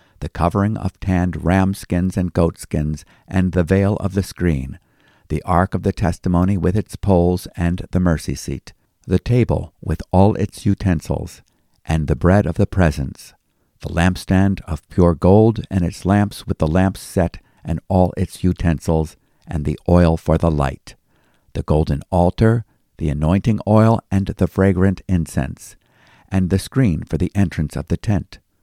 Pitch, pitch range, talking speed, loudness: 90 Hz, 80-100 Hz, 165 wpm, -19 LUFS